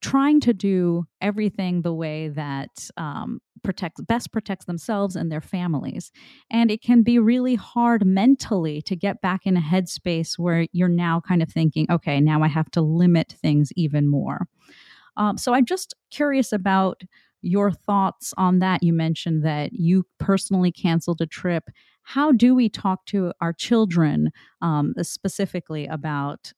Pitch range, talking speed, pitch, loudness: 165-205 Hz, 160 wpm, 180 Hz, -22 LUFS